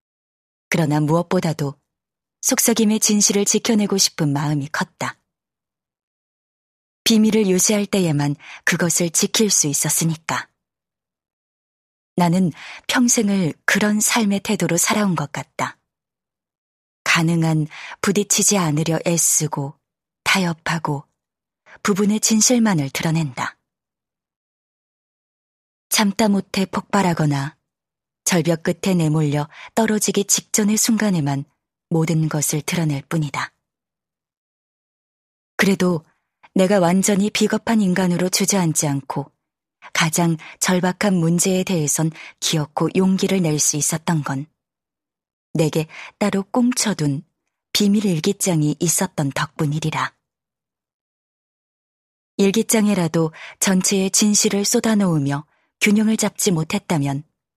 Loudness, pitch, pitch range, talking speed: -19 LUFS, 175 Hz, 155-205 Hz, 230 characters per minute